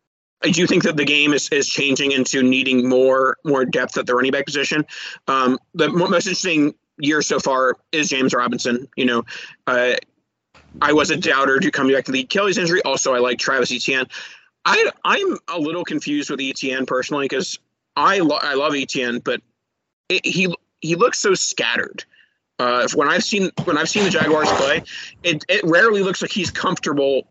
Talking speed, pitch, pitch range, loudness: 190 wpm, 145 Hz, 130-175 Hz, -18 LUFS